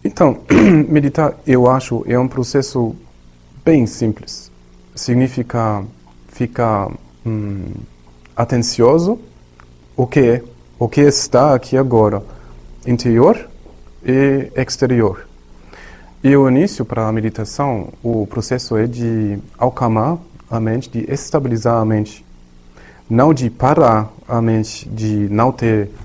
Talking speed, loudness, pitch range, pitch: 115 wpm, -15 LUFS, 100-130 Hz, 115 Hz